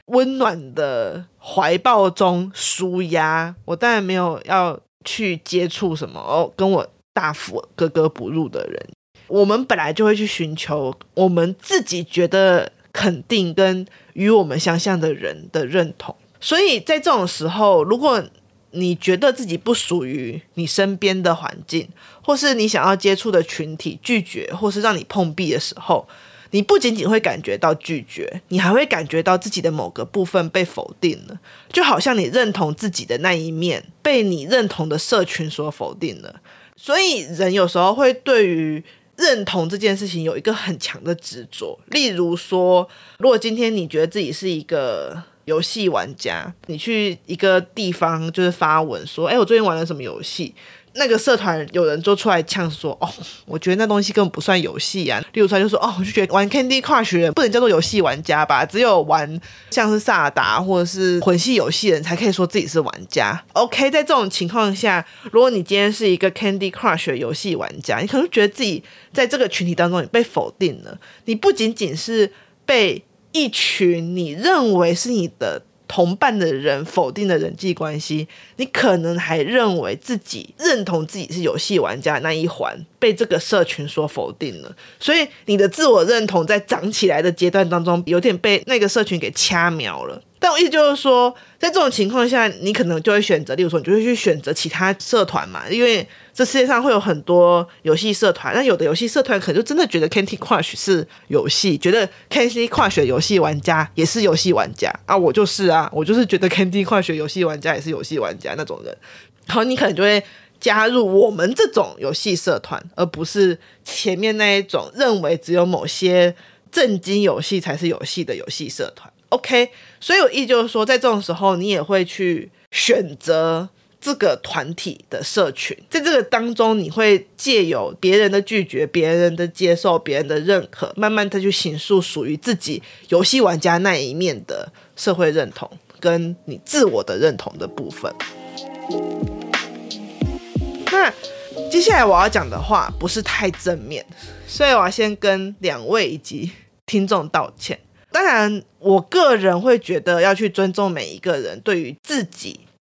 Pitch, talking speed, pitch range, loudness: 190 Hz, 290 characters per minute, 170-225 Hz, -18 LUFS